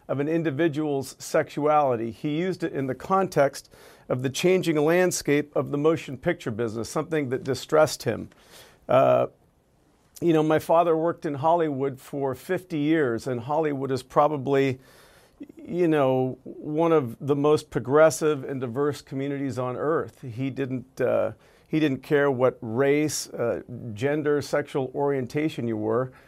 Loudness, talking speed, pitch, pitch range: -25 LUFS, 145 wpm, 145 Hz, 130-155 Hz